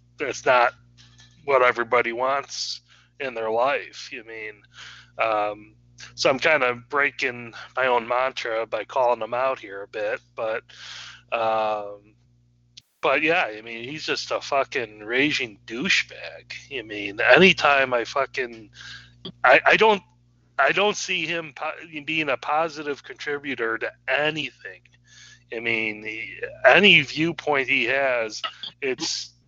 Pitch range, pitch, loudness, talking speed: 110-145 Hz, 120 Hz, -22 LUFS, 130 wpm